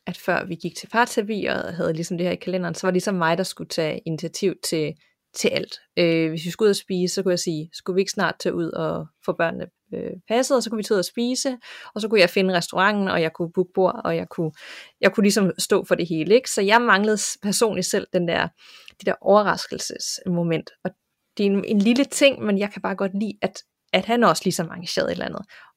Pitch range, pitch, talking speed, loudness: 170-210 Hz, 185 Hz, 255 wpm, -22 LUFS